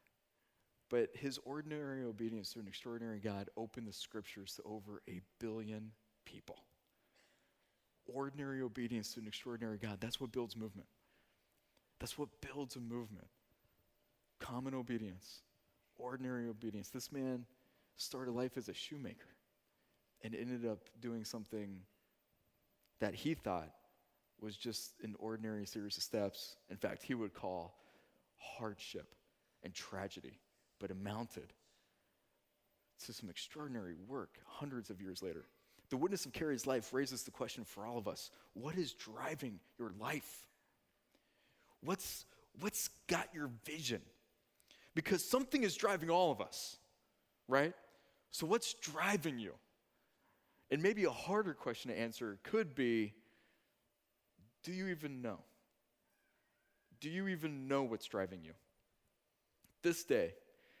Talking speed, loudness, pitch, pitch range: 130 wpm, -43 LUFS, 120 Hz, 105-135 Hz